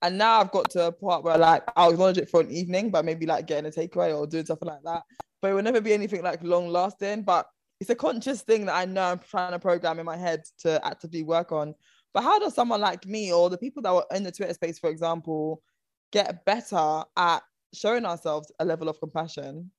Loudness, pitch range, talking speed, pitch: -26 LUFS, 165-195 Hz, 245 wpm, 175 Hz